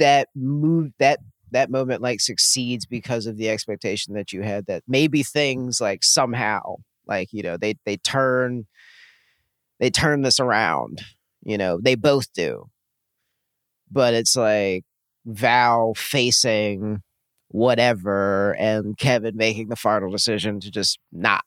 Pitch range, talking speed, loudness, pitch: 105-130 Hz, 135 wpm, -21 LUFS, 115 Hz